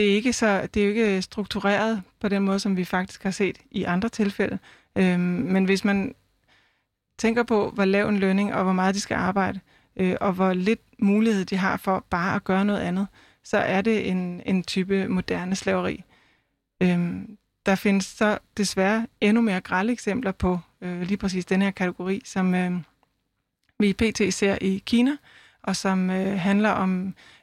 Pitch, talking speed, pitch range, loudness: 195 Hz, 190 wpm, 185-210 Hz, -24 LUFS